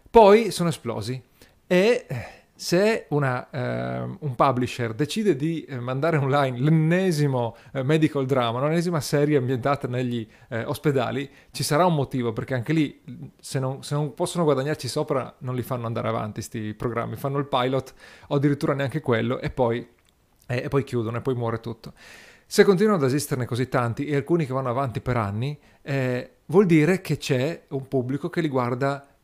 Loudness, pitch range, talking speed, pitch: -24 LUFS, 125-150 Hz, 170 wpm, 135 Hz